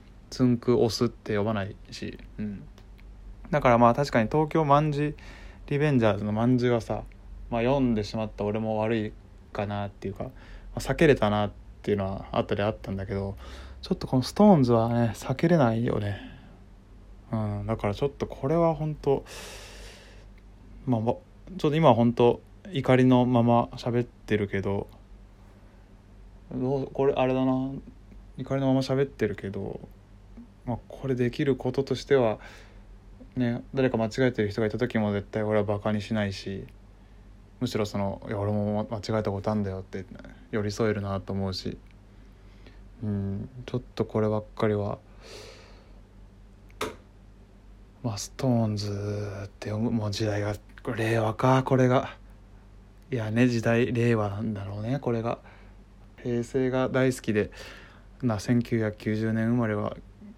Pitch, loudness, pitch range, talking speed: 105 Hz, -27 LUFS, 100-125 Hz, 285 characters per minute